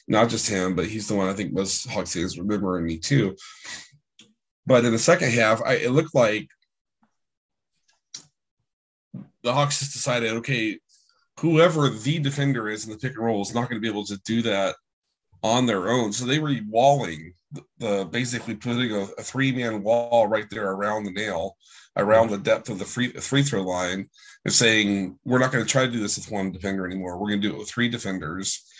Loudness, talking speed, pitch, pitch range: -23 LUFS, 200 wpm, 115 Hz, 100-130 Hz